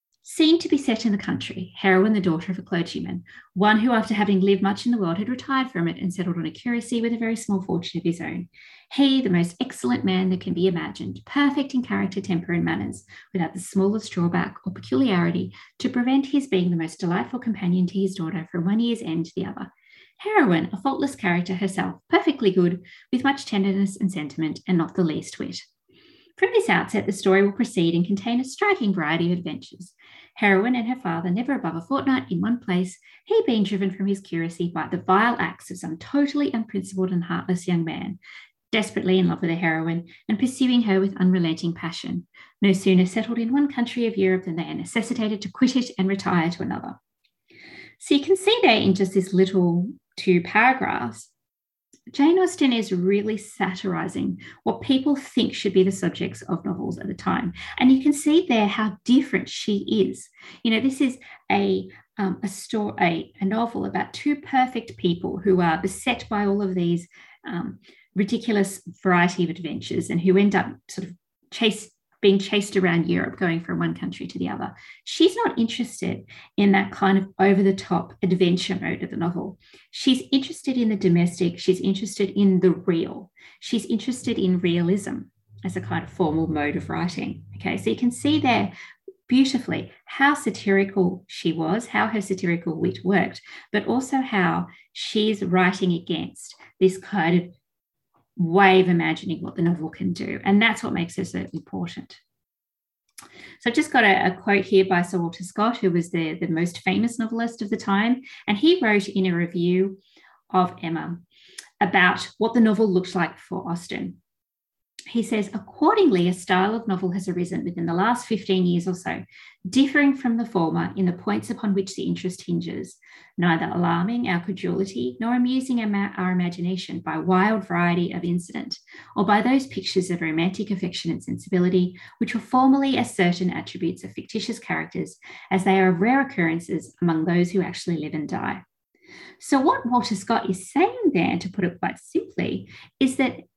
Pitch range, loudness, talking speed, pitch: 175-235 Hz, -23 LUFS, 190 wpm, 195 Hz